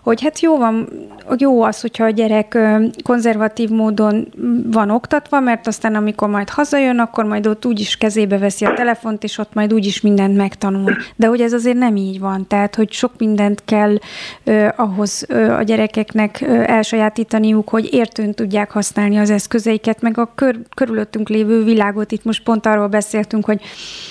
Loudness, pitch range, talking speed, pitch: -16 LUFS, 210-230 Hz, 175 wpm, 220 Hz